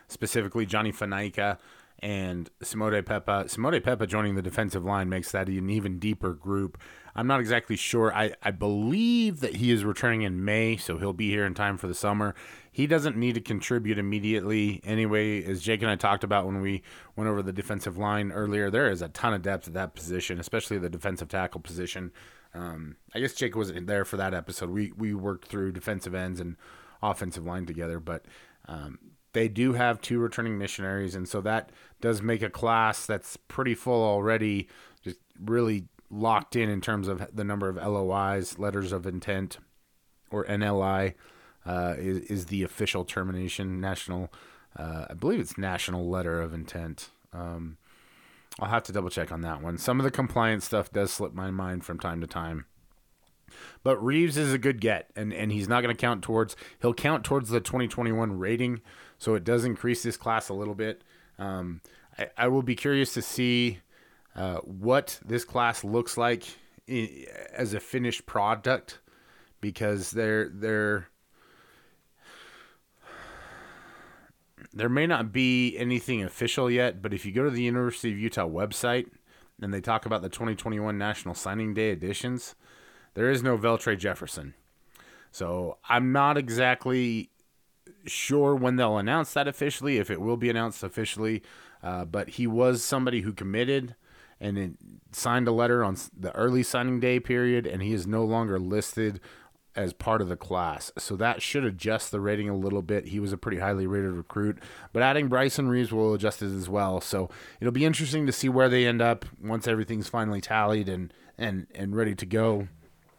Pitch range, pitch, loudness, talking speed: 95-120 Hz, 105 Hz, -28 LUFS, 180 wpm